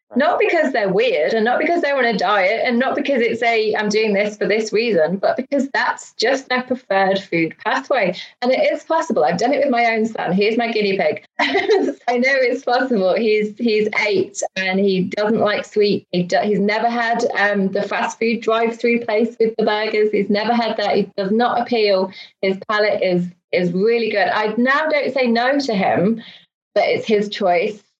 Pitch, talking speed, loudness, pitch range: 225 Hz, 205 wpm, -18 LUFS, 205-250 Hz